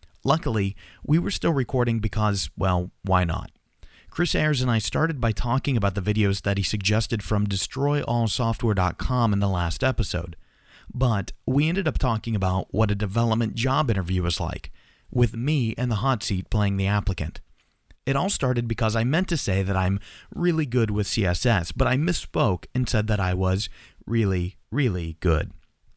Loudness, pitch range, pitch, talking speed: -24 LUFS, 95-125 Hz, 110 Hz, 175 wpm